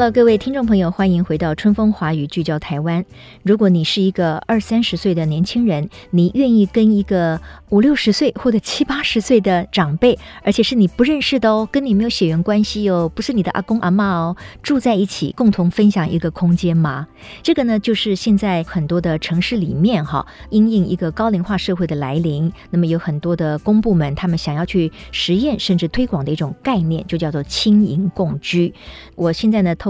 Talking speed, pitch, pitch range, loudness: 310 characters per minute, 190 Hz, 170-220 Hz, -17 LUFS